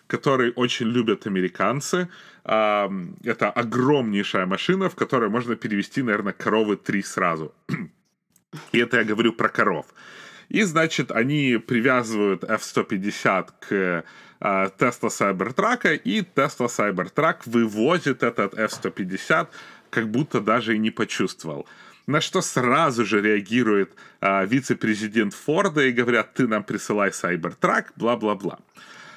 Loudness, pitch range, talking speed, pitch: -23 LUFS, 105-130 Hz, 115 wpm, 115 Hz